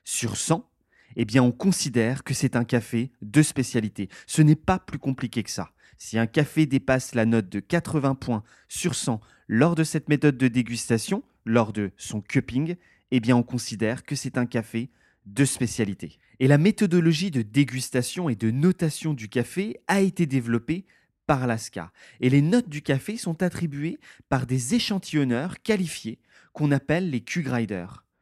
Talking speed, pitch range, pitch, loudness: 170 wpm, 115-155 Hz, 130 Hz, -25 LUFS